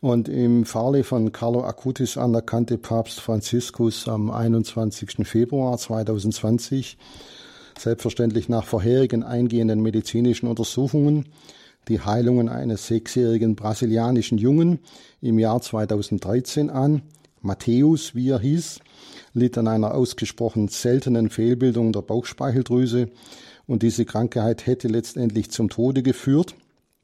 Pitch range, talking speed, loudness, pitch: 115-125 Hz, 110 wpm, -22 LUFS, 120 Hz